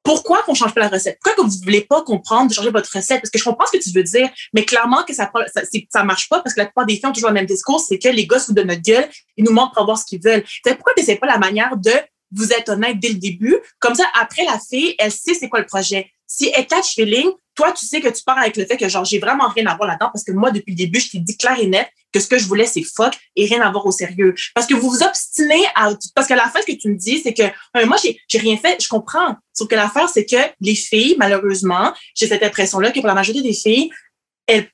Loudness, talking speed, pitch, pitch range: -16 LUFS, 300 wpm, 225 Hz, 205-260 Hz